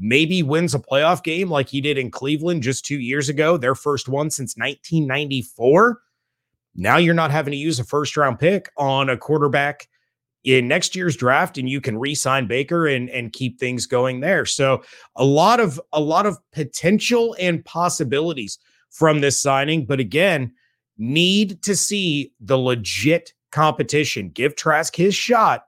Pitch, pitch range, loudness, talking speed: 145 Hz, 130-165 Hz, -19 LUFS, 170 wpm